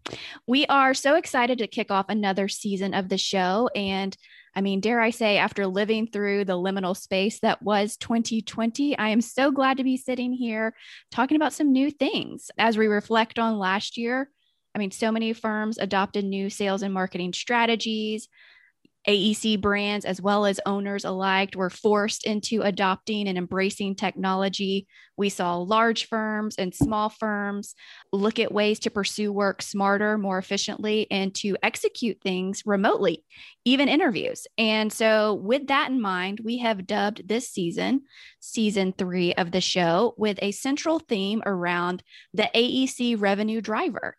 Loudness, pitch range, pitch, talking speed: -25 LUFS, 195-230 Hz, 210 Hz, 160 wpm